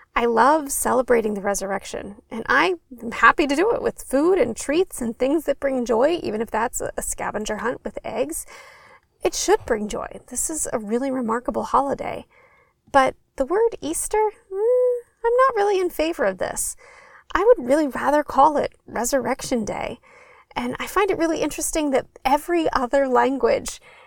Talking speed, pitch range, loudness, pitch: 170 wpm, 255-410 Hz, -22 LUFS, 300 Hz